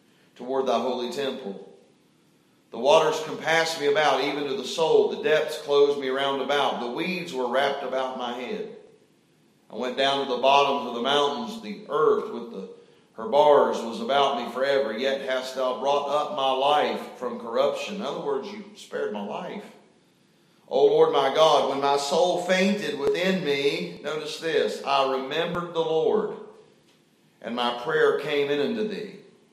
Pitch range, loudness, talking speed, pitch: 135-190 Hz, -24 LUFS, 175 wpm, 145 Hz